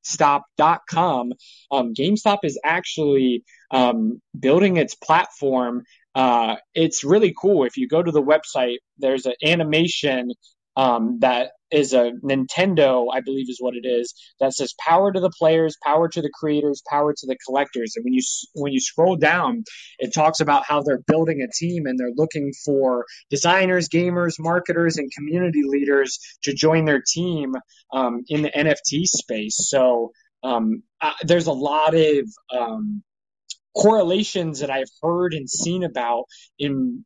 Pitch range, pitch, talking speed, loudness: 130-175 Hz, 150 Hz, 155 wpm, -20 LUFS